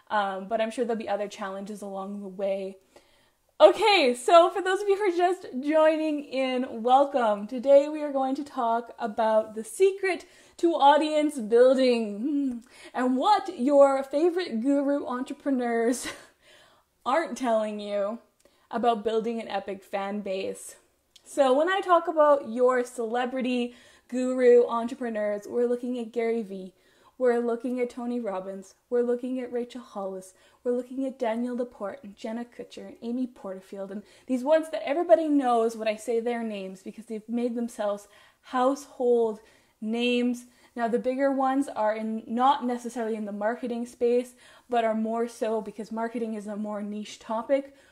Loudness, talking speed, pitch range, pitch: -26 LUFS, 155 wpm, 220-275 Hz, 240 Hz